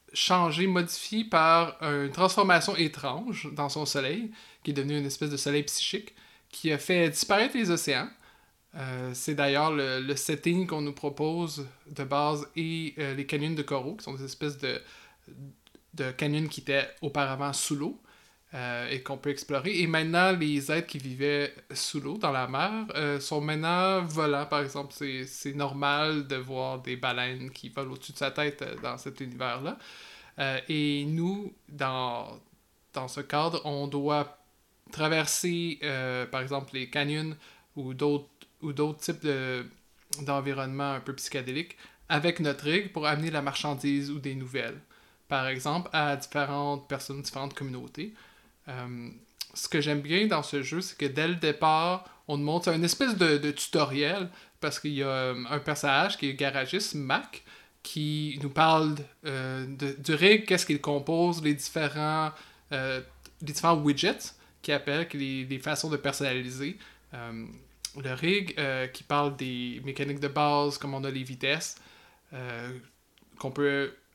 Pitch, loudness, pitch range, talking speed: 145 Hz, -29 LUFS, 140-160 Hz, 170 wpm